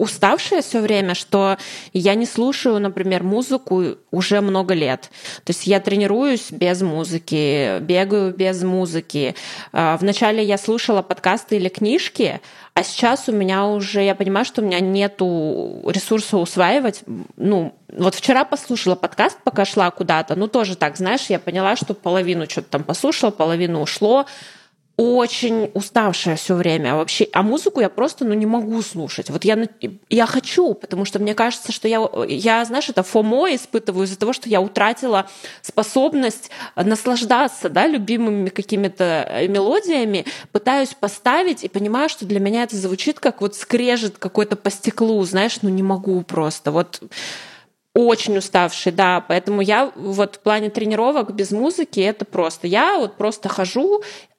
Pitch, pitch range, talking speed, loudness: 205 Hz, 185-230 Hz, 150 wpm, -19 LUFS